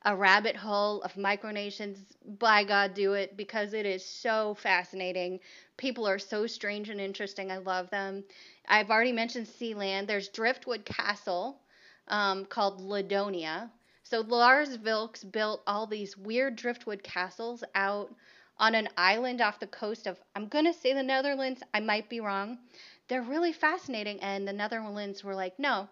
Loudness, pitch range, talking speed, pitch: -30 LUFS, 195-230 Hz, 155 wpm, 210 Hz